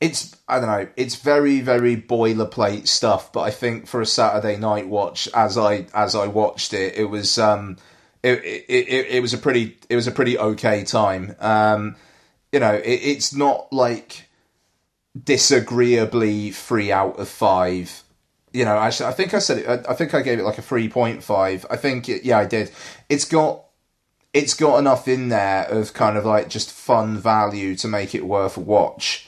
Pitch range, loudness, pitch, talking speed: 105-125 Hz, -20 LUFS, 110 Hz, 195 wpm